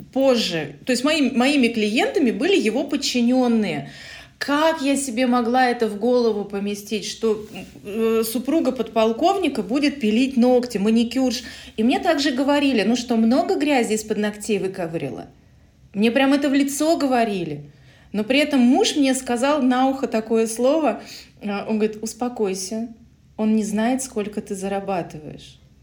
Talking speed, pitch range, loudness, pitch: 145 wpm, 215-270 Hz, -20 LUFS, 240 Hz